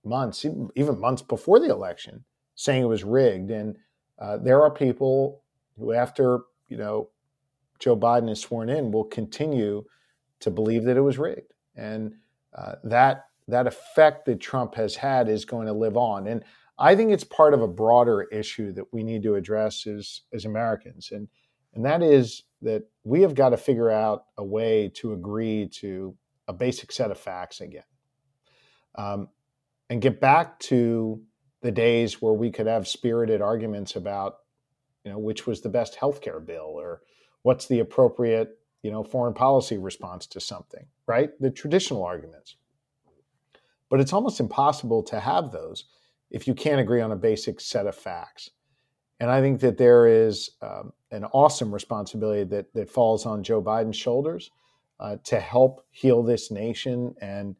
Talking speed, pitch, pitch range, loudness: 170 wpm, 120 Hz, 110-135 Hz, -24 LUFS